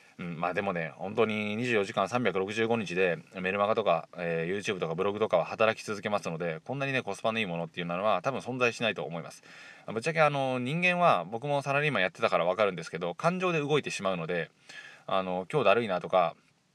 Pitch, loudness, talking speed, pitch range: 110 Hz, -29 LUFS, 455 characters per minute, 95-135 Hz